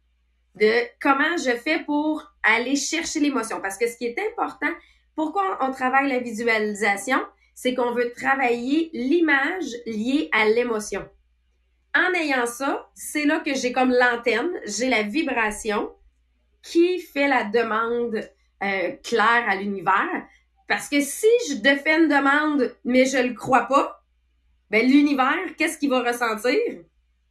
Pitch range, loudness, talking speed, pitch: 220-295 Hz, -22 LUFS, 145 wpm, 250 Hz